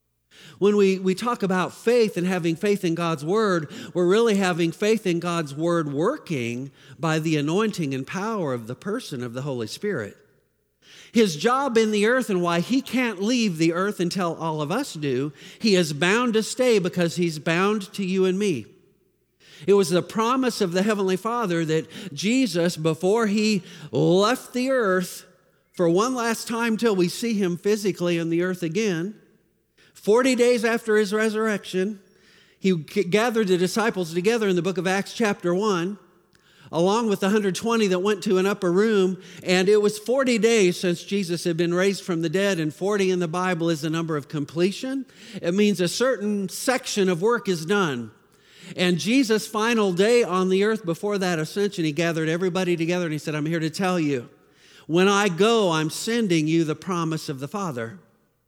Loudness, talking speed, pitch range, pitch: -23 LUFS, 185 wpm, 170-215 Hz, 185 Hz